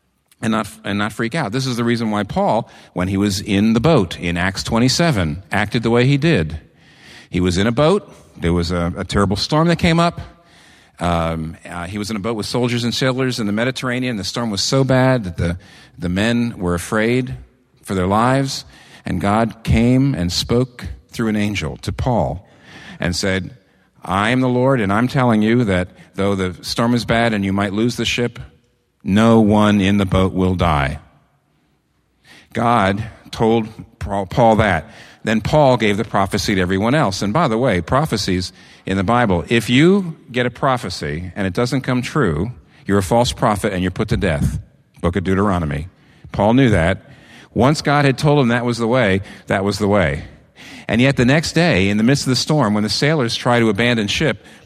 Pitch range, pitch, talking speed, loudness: 95-125 Hz, 110 Hz, 200 wpm, -17 LUFS